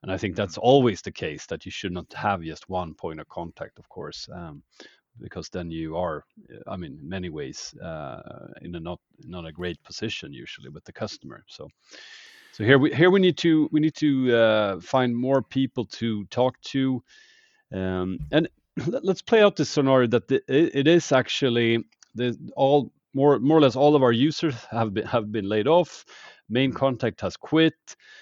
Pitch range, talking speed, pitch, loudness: 100-150 Hz, 200 wpm, 130 Hz, -23 LUFS